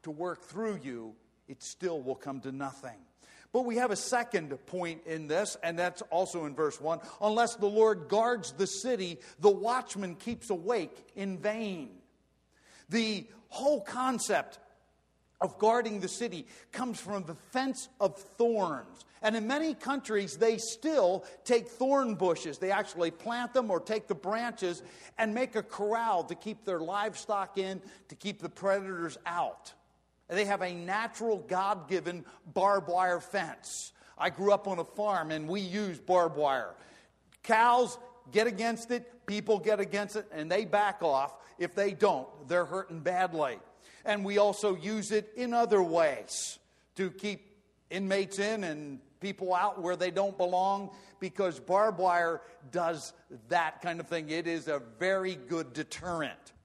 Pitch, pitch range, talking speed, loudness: 195 Hz, 175-220 Hz, 160 wpm, -32 LUFS